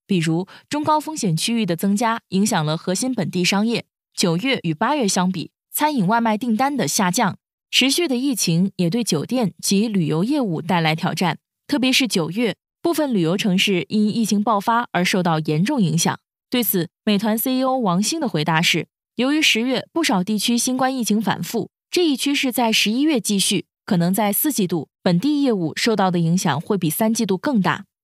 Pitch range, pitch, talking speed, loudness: 180-250 Hz, 210 Hz, 290 characters per minute, -20 LUFS